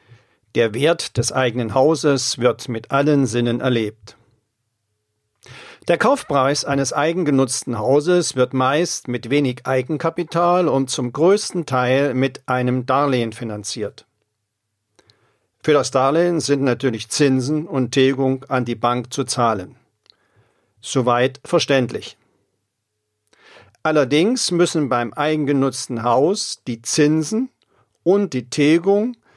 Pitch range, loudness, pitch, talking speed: 120-150 Hz, -19 LUFS, 130 Hz, 110 wpm